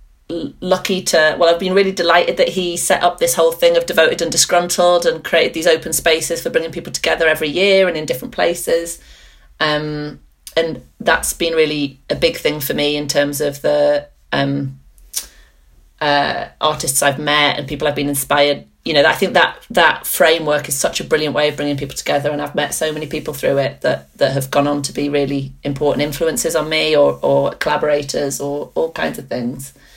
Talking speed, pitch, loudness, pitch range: 200 wpm, 150 Hz, -16 LUFS, 145-175 Hz